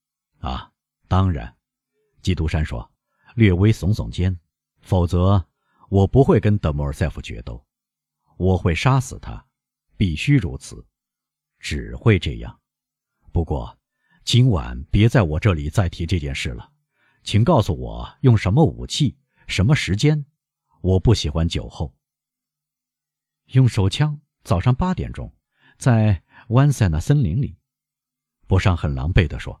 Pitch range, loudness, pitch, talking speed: 80-130 Hz, -20 LUFS, 105 Hz, 190 characters per minute